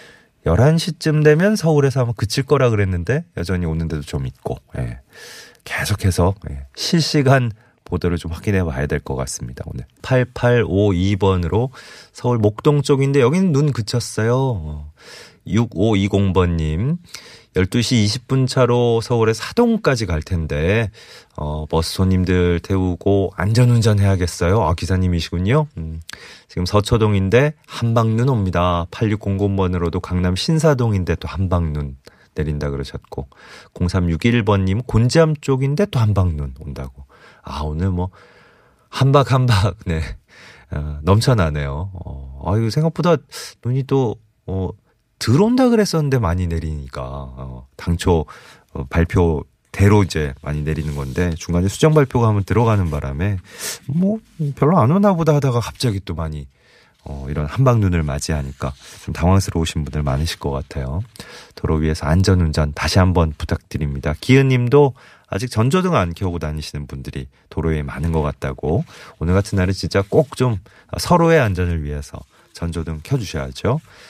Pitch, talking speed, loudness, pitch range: 95 Hz, 290 characters per minute, -18 LUFS, 80-120 Hz